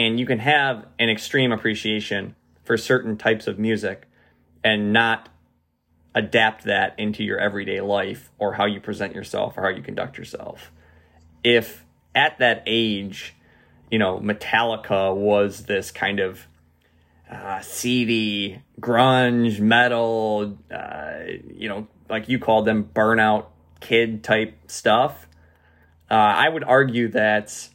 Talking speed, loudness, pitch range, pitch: 130 wpm, -21 LUFS, 95-115 Hz, 105 Hz